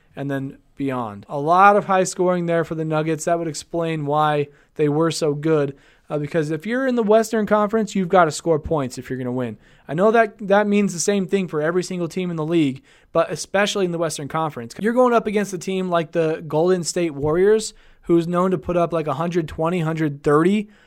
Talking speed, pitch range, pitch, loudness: 225 wpm, 155-190 Hz, 170 Hz, -20 LUFS